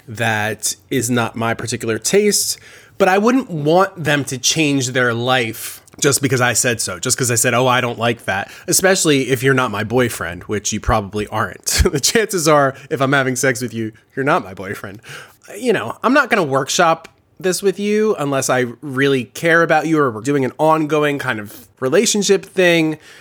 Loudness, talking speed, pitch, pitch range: -16 LUFS, 200 wpm, 135 Hz, 120-160 Hz